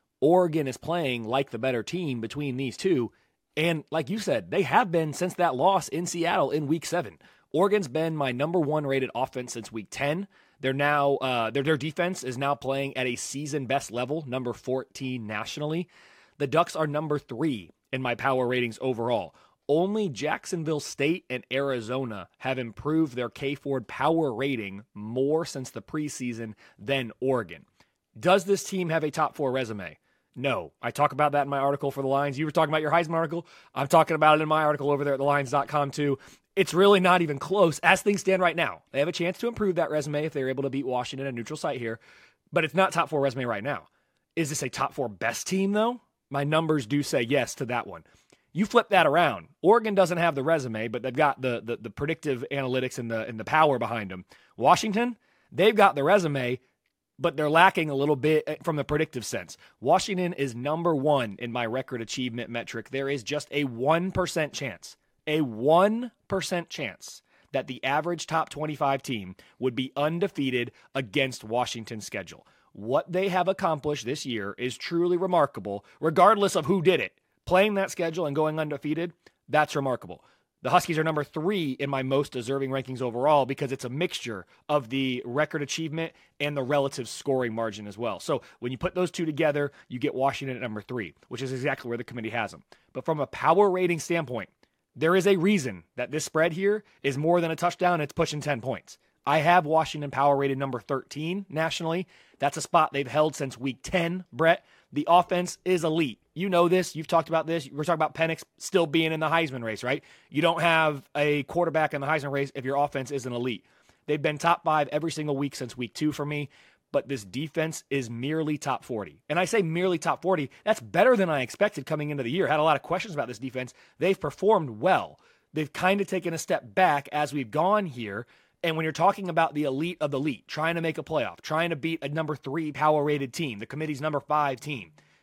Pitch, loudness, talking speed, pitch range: 150 Hz, -27 LUFS, 210 wpm, 130-165 Hz